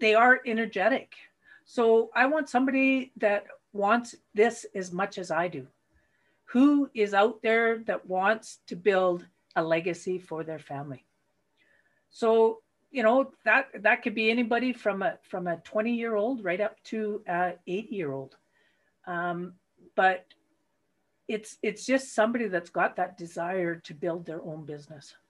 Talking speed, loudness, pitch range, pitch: 155 wpm, -27 LUFS, 175-230 Hz, 210 Hz